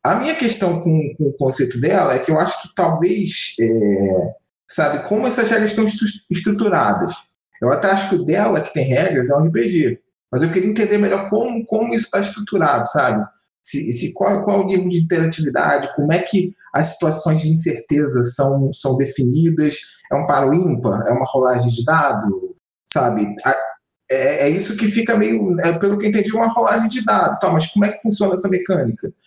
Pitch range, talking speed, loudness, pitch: 145-210 Hz, 200 wpm, -16 LUFS, 180 Hz